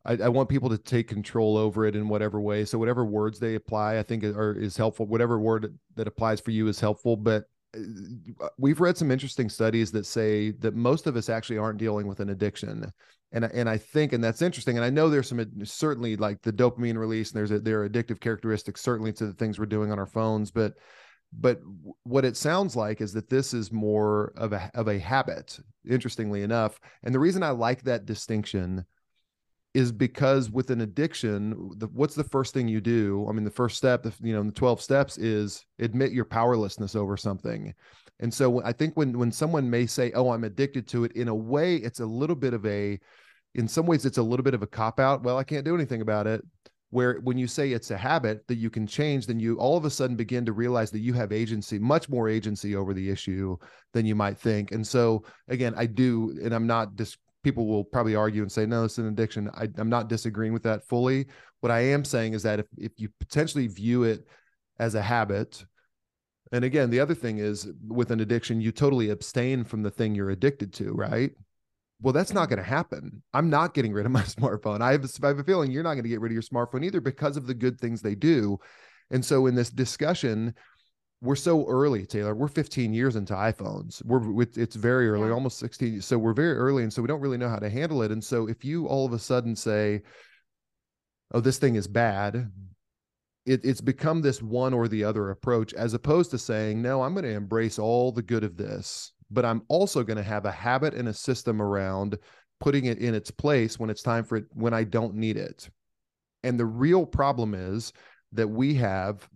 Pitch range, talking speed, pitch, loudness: 110-130 Hz, 225 wpm, 115 Hz, -27 LUFS